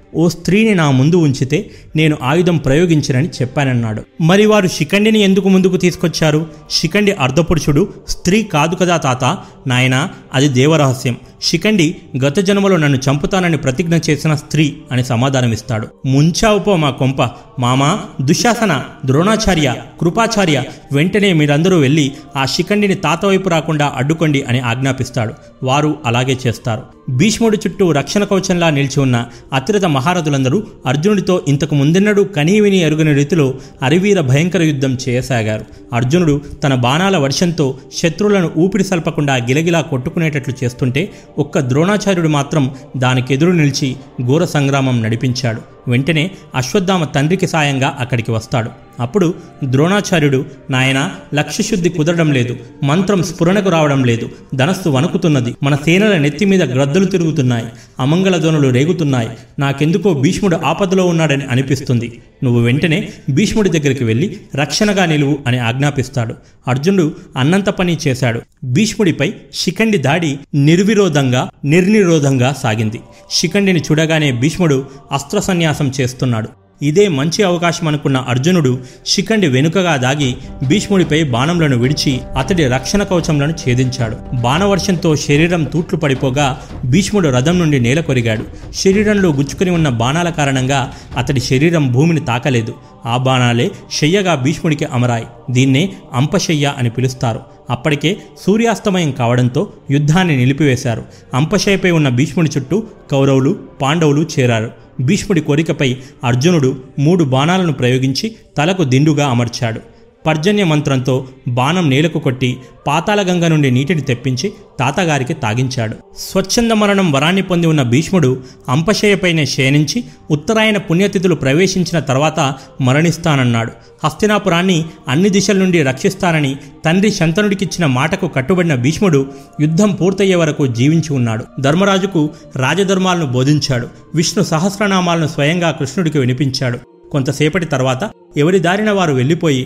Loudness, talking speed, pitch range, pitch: -14 LUFS, 115 wpm, 130-180 Hz, 150 Hz